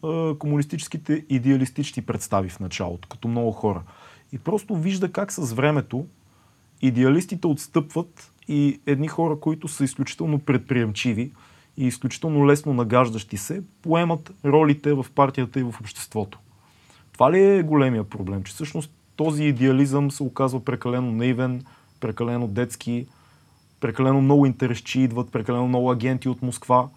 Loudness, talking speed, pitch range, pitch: -23 LUFS, 130 wpm, 120-150 Hz, 130 Hz